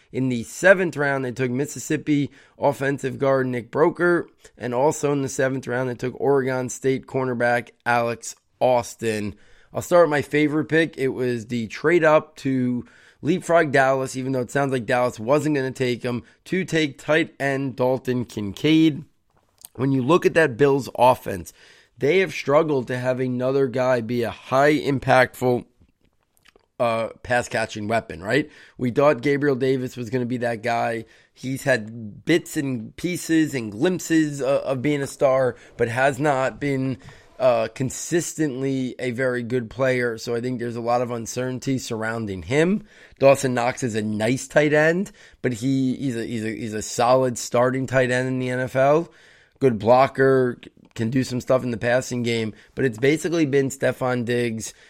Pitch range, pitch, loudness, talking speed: 120-140 Hz, 130 Hz, -22 LUFS, 175 wpm